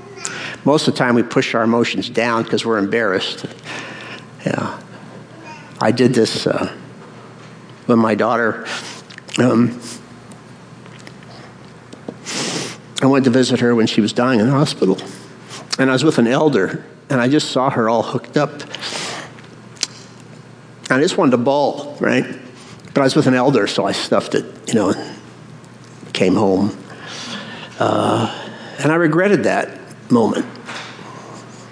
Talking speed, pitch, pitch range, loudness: 140 wpm, 125 Hz, 115-135 Hz, -17 LUFS